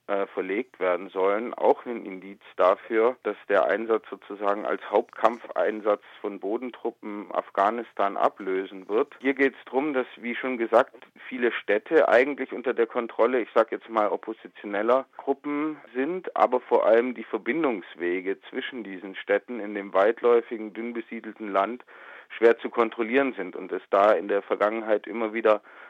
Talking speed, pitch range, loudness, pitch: 150 wpm, 100-125 Hz, -26 LUFS, 115 Hz